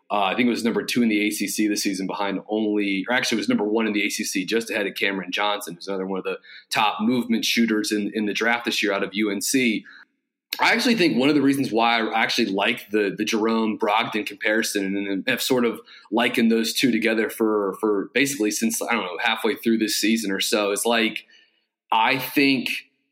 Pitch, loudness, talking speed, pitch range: 110 Hz, -22 LUFS, 225 wpm, 105-115 Hz